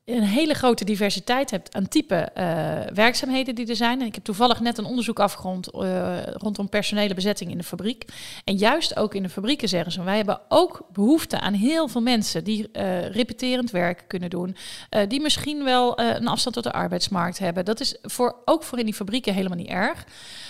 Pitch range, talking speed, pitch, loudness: 190-245 Hz, 205 wpm, 215 Hz, -24 LUFS